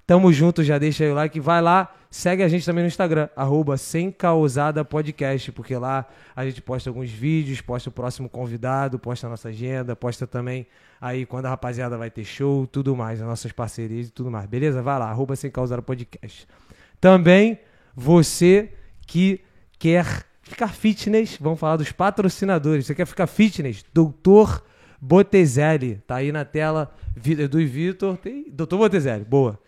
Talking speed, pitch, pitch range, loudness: 160 wpm, 145 Hz, 125-170 Hz, -21 LUFS